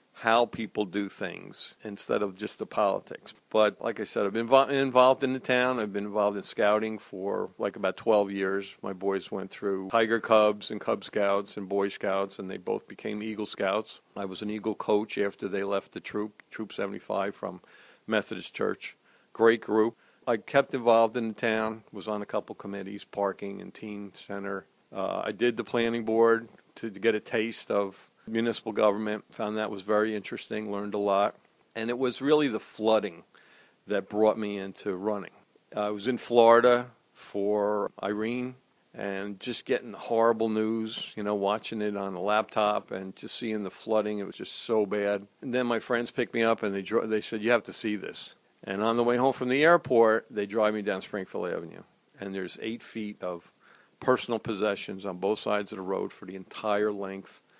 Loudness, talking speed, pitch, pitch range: -29 LUFS, 195 wpm, 105 Hz, 100-115 Hz